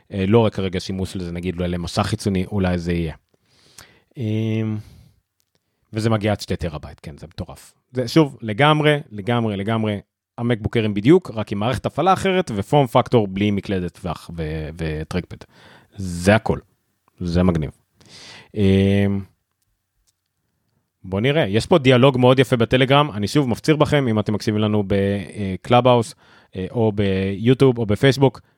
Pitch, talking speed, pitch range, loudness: 105 Hz, 135 wpm, 95-120 Hz, -19 LUFS